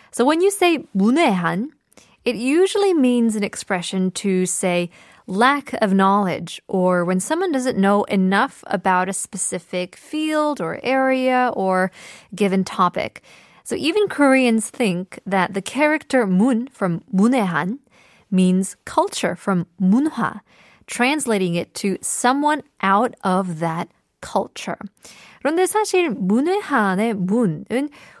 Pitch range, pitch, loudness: 190-265 Hz, 215 Hz, -20 LUFS